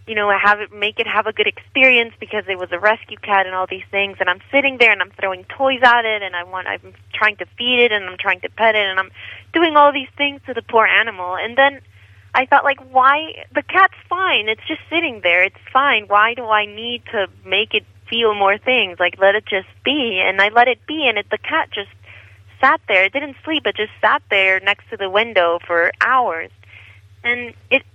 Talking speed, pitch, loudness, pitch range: 240 wpm, 215 Hz, -16 LUFS, 190-260 Hz